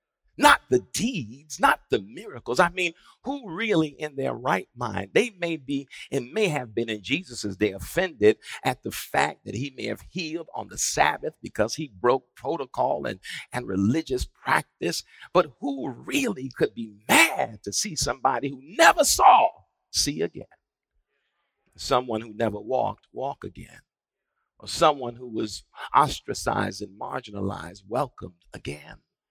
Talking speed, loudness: 150 wpm, -25 LUFS